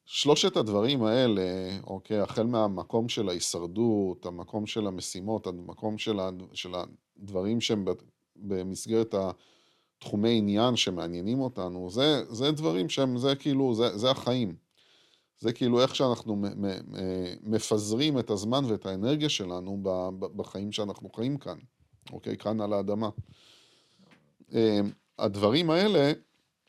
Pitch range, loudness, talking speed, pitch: 95-120 Hz, -29 LUFS, 110 wpm, 110 Hz